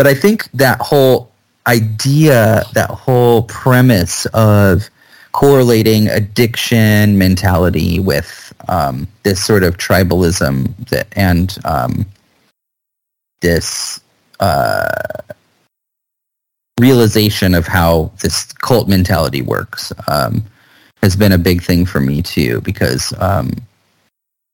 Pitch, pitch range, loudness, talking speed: 105 Hz, 90-120 Hz, -13 LUFS, 105 wpm